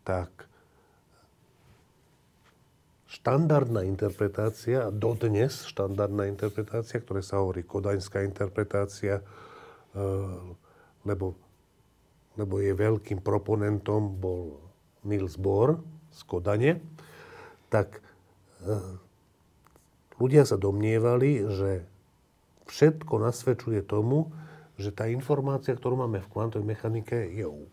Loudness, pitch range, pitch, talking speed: -29 LUFS, 95-120 Hz, 105 Hz, 85 wpm